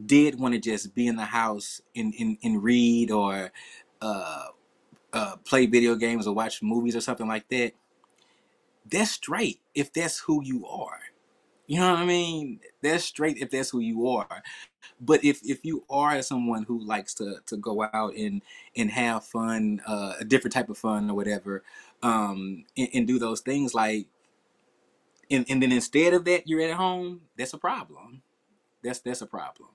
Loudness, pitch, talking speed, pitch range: -27 LUFS, 125 Hz, 185 wpm, 115-155 Hz